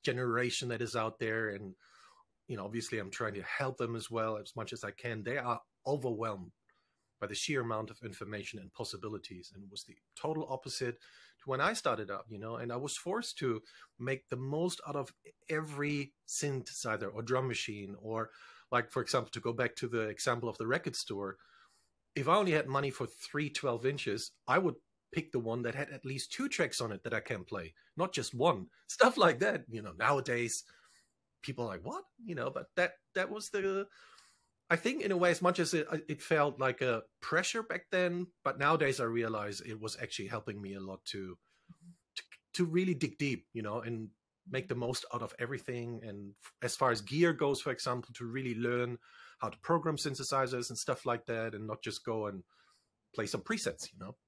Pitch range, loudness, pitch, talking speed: 110-145 Hz, -36 LUFS, 120 Hz, 210 wpm